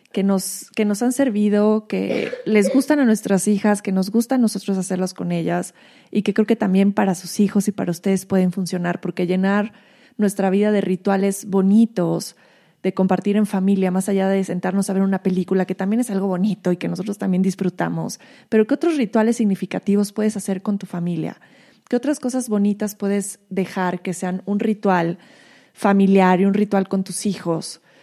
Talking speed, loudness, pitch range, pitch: 190 wpm, -20 LUFS, 185-215 Hz, 195 Hz